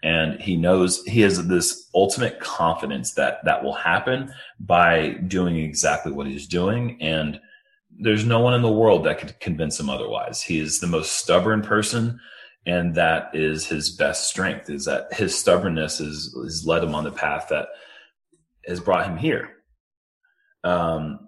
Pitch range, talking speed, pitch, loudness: 80-110 Hz, 165 wpm, 90 Hz, -22 LUFS